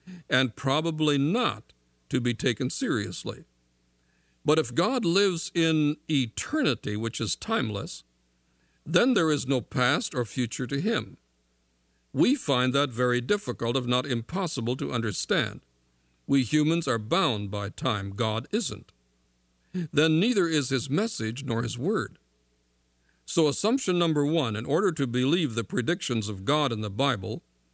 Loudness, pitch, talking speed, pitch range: -27 LUFS, 125 Hz, 145 wpm, 90-150 Hz